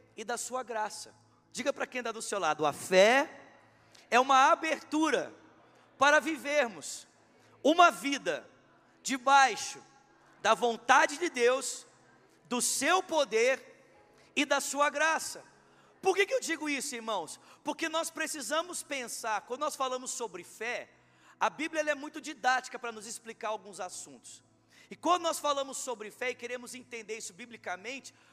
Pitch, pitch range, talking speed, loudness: 265 Hz, 235-300 Hz, 150 wpm, -30 LUFS